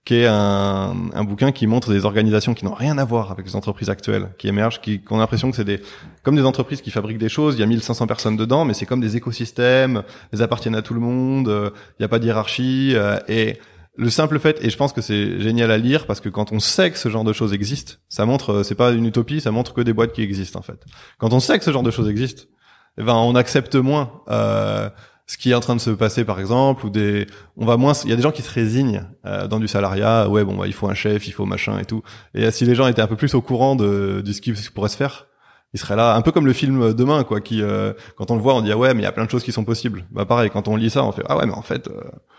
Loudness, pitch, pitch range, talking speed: -19 LUFS, 115 Hz, 105-125 Hz, 300 wpm